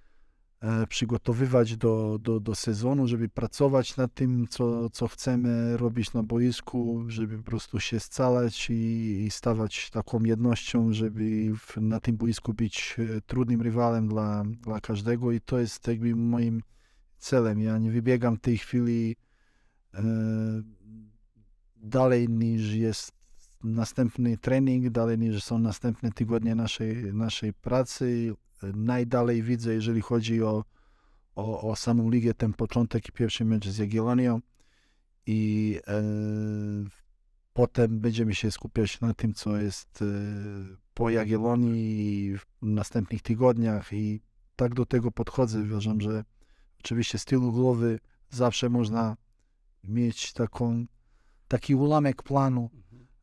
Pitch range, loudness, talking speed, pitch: 110-120 Hz, -28 LUFS, 125 wpm, 115 Hz